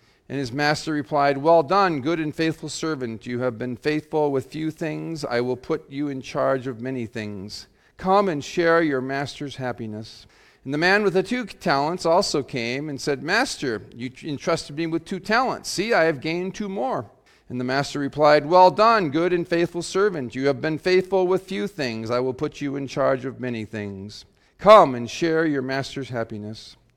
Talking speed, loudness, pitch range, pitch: 195 wpm, -22 LUFS, 125-165 Hz, 145 Hz